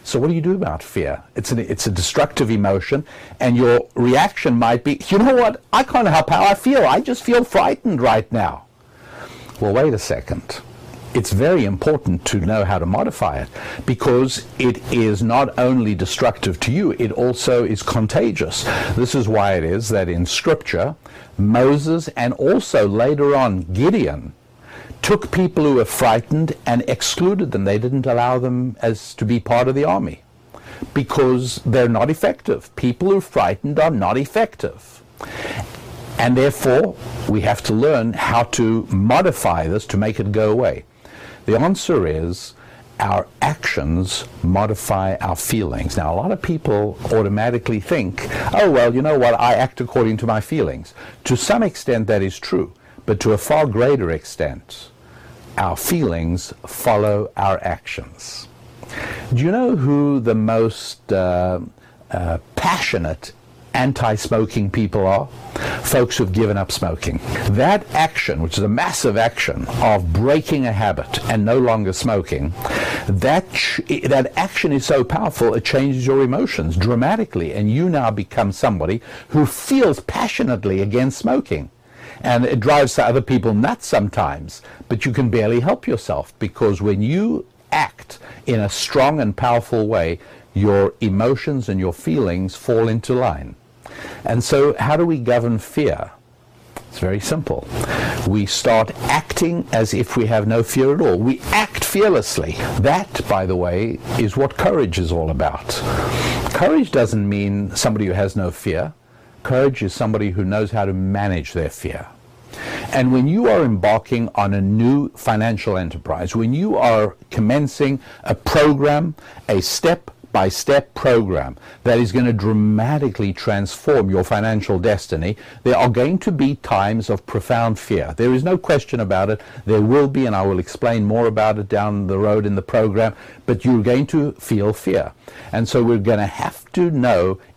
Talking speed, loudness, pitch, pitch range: 160 wpm, -18 LUFS, 115 Hz, 100-130 Hz